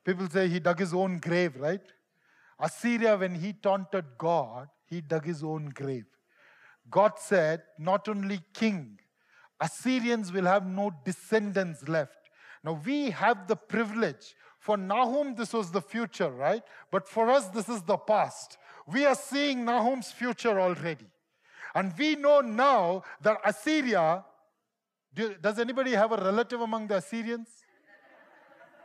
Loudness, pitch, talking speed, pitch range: -29 LUFS, 200 Hz, 140 wpm, 175-230 Hz